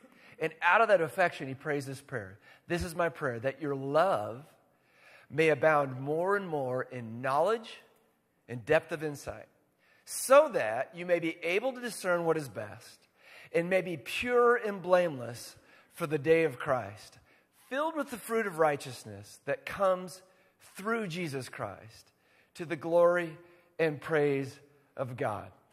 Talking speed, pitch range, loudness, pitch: 155 wpm, 135-180 Hz, -30 LUFS, 160 Hz